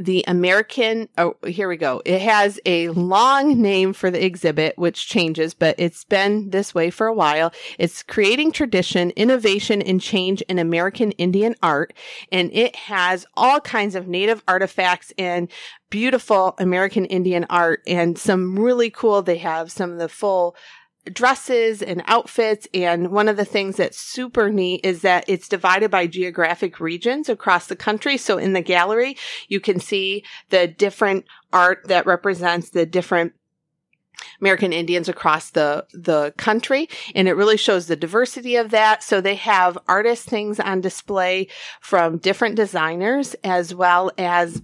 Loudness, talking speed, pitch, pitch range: -19 LUFS, 160 wpm, 190 Hz, 175-215 Hz